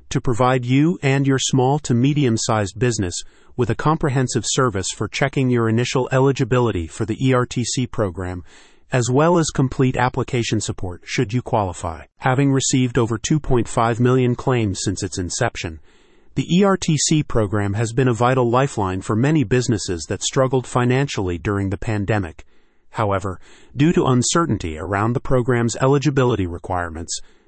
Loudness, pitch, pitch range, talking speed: -19 LUFS, 125 Hz, 105-135 Hz, 145 wpm